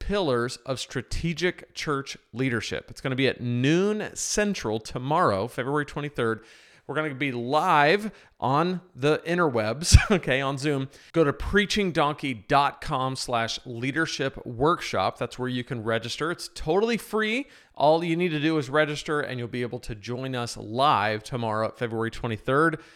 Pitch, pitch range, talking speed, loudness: 140 Hz, 120-165 Hz, 145 wpm, -26 LUFS